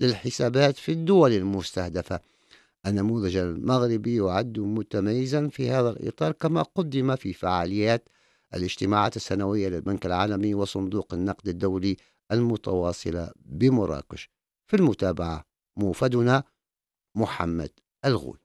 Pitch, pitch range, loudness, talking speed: 100 Hz, 95-125 Hz, -26 LUFS, 95 wpm